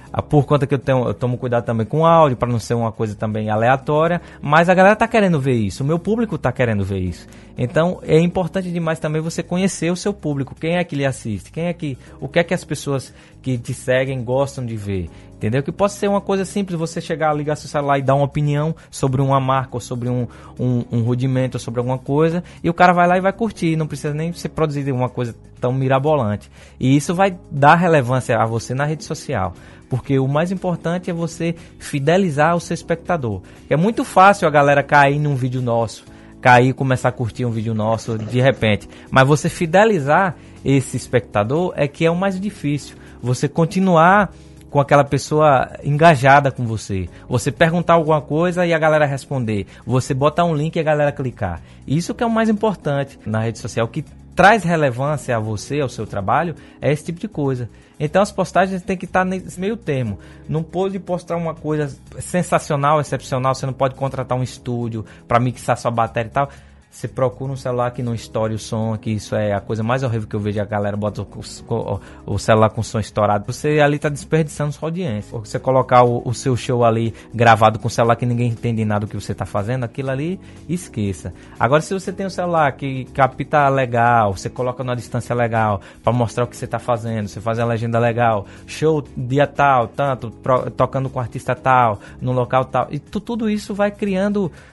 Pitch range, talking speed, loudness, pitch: 115-160 Hz, 215 wpm, -19 LUFS, 135 Hz